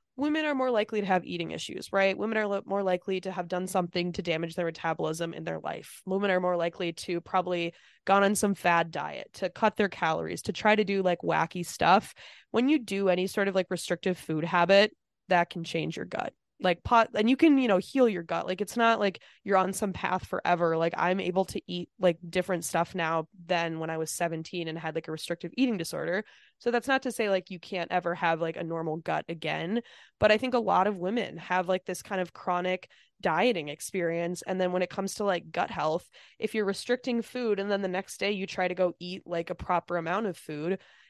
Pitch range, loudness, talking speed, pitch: 170-200 Hz, -29 LUFS, 235 wpm, 185 Hz